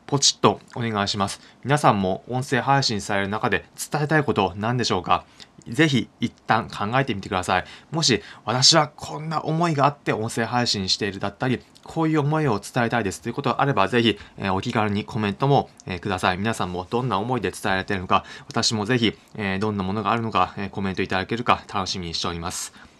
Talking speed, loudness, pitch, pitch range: 430 characters per minute, -23 LUFS, 110 Hz, 95-130 Hz